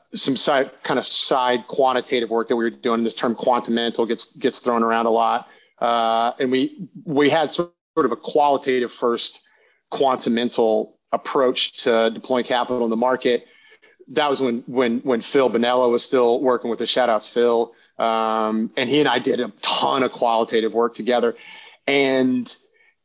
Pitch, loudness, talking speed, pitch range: 120 Hz, -20 LUFS, 175 wpm, 115-130 Hz